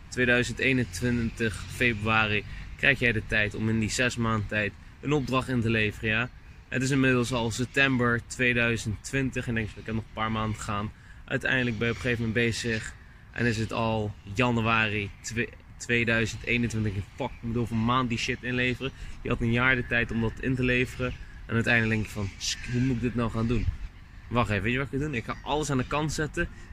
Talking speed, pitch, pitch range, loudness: 220 wpm, 115 Hz, 110-125 Hz, -27 LUFS